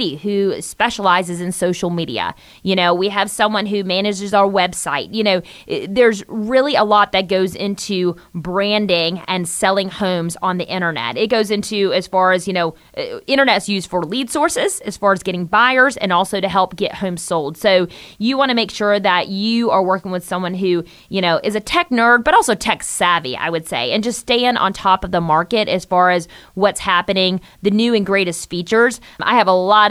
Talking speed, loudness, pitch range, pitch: 205 wpm, -17 LUFS, 180-210 Hz, 195 Hz